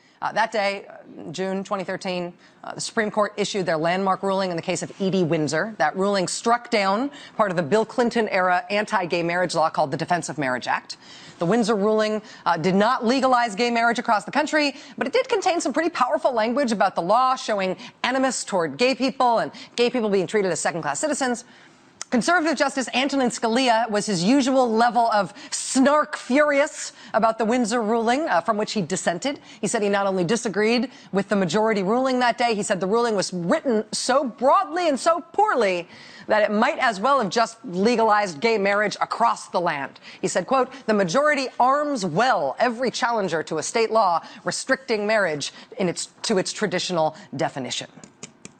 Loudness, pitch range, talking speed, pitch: -22 LUFS, 195-255 Hz, 190 wpm, 225 Hz